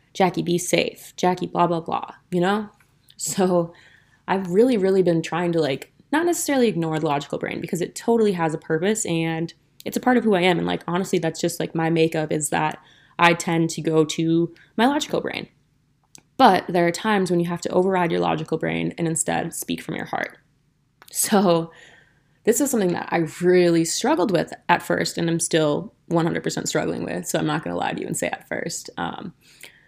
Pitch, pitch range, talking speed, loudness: 170 Hz, 160-185 Hz, 205 wpm, -22 LUFS